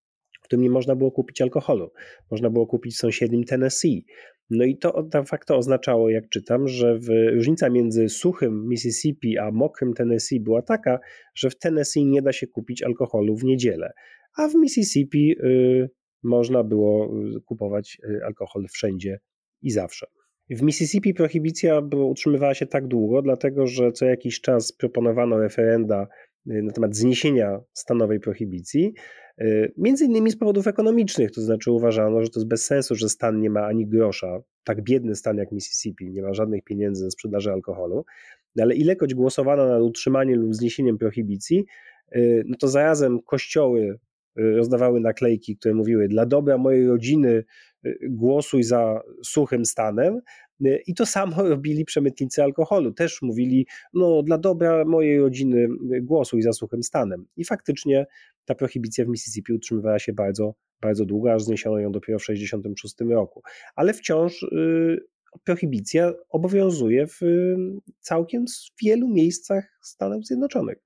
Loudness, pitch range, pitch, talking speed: -22 LUFS, 110-150 Hz, 125 Hz, 145 wpm